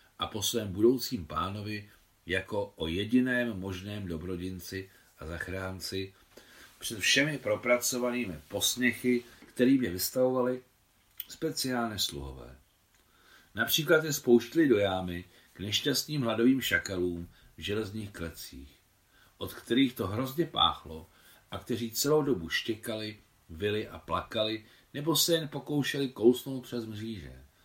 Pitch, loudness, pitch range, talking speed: 105 Hz, -30 LUFS, 95-125 Hz, 115 wpm